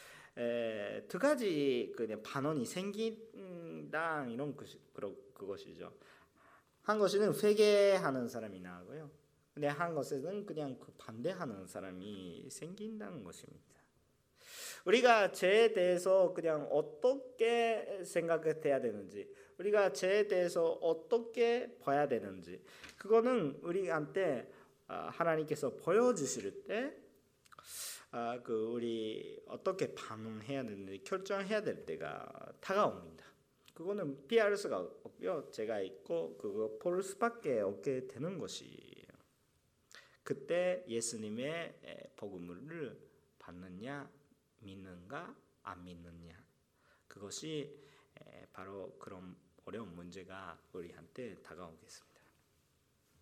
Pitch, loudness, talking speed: 165 Hz, -36 LUFS, 235 characters per minute